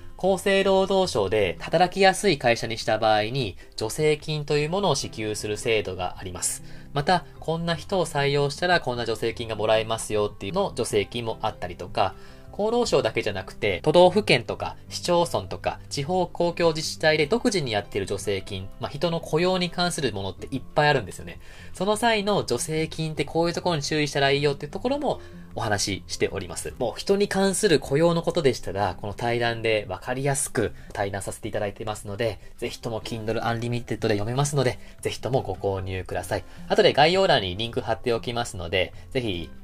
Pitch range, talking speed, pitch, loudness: 105-165 Hz, 435 characters per minute, 120 Hz, -25 LUFS